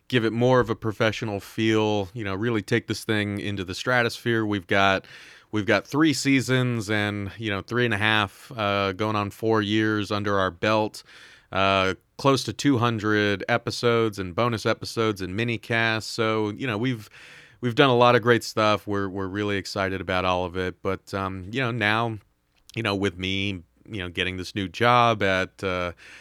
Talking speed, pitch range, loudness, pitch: 190 wpm, 95-115 Hz, -24 LUFS, 105 Hz